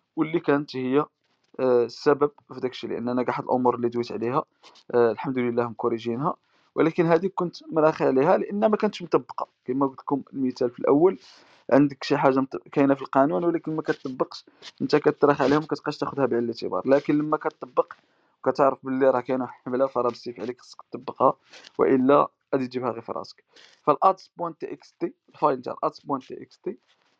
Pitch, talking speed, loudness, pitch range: 140 Hz, 155 wpm, -24 LUFS, 130-155 Hz